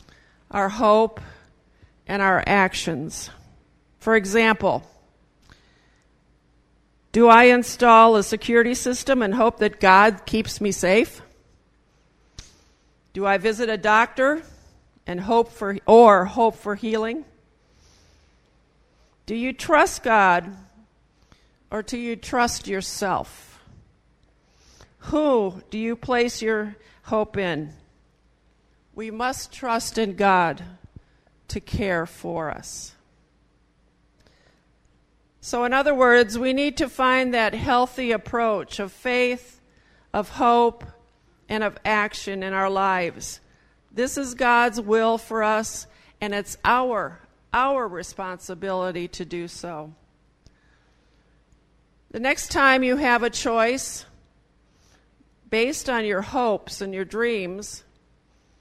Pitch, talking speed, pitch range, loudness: 220 Hz, 110 wpm, 195-240 Hz, -21 LUFS